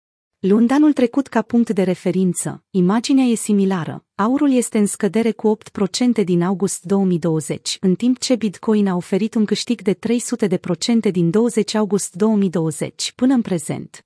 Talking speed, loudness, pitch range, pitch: 155 wpm, -18 LUFS, 180-230 Hz, 205 Hz